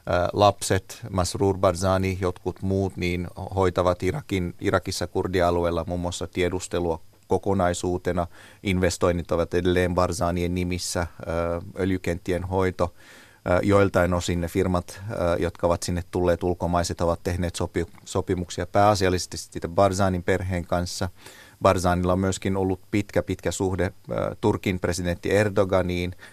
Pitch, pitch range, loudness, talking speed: 90 Hz, 90-95 Hz, -25 LUFS, 110 wpm